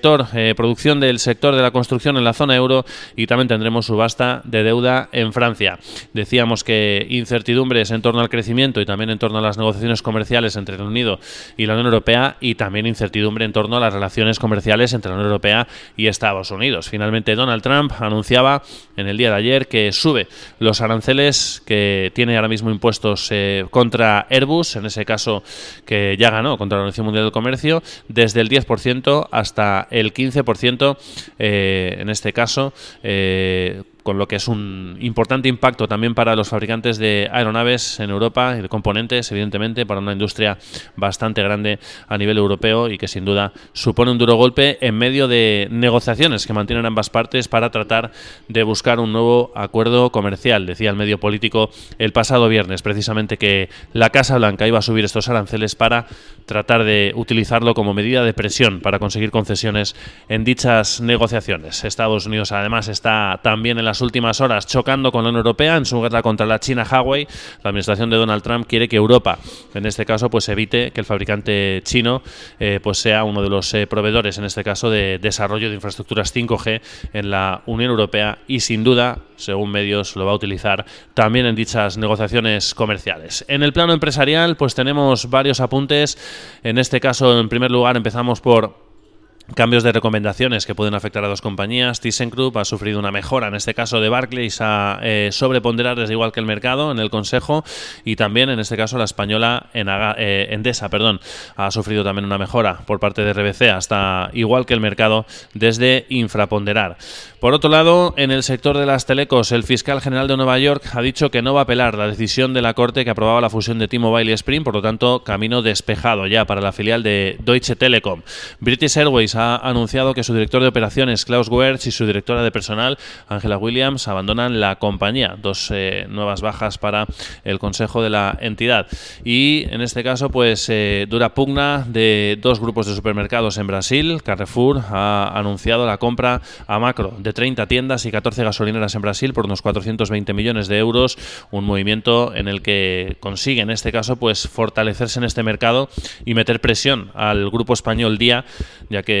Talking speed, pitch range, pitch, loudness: 190 wpm, 105-125 Hz, 115 Hz, -17 LUFS